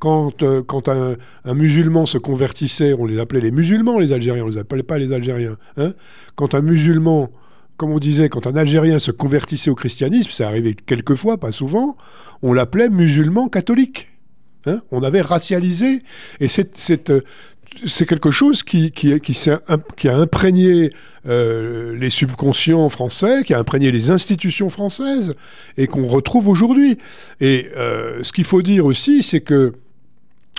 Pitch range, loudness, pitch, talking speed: 135-185 Hz, -16 LUFS, 155 Hz, 165 wpm